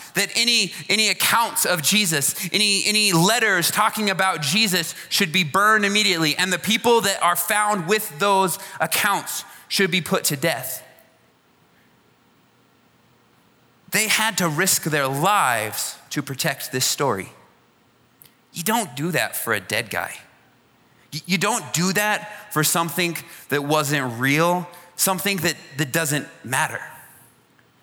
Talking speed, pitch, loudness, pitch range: 135 wpm, 180 Hz, -20 LUFS, 160-205 Hz